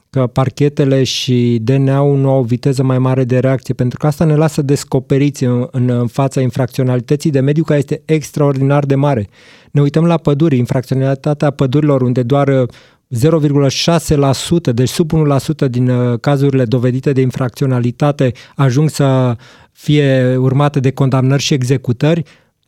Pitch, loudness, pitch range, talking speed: 135 Hz, -13 LUFS, 130-145 Hz, 145 wpm